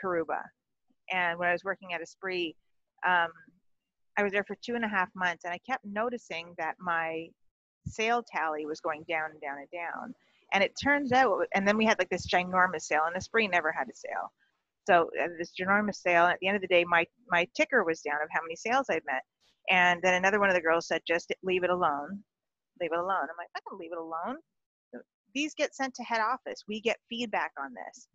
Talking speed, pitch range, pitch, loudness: 230 wpm, 170-225 Hz, 180 Hz, -29 LUFS